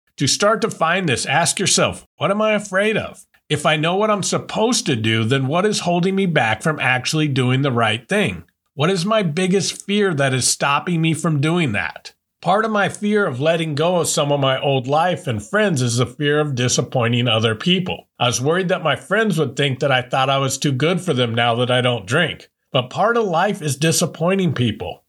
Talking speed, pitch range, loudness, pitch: 225 wpm, 130-185 Hz, -18 LUFS, 155 Hz